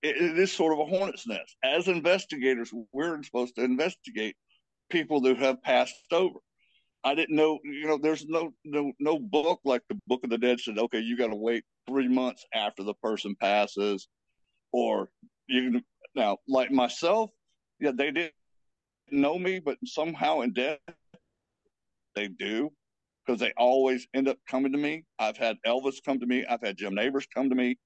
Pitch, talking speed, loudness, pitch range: 135 Hz, 180 wpm, -28 LUFS, 125-160 Hz